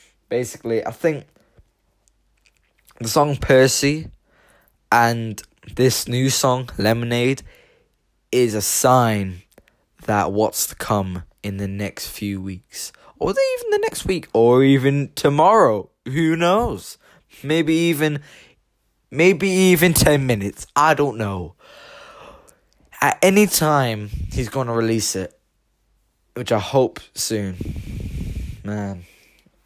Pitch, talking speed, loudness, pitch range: 120 Hz, 110 wpm, -19 LUFS, 105-145 Hz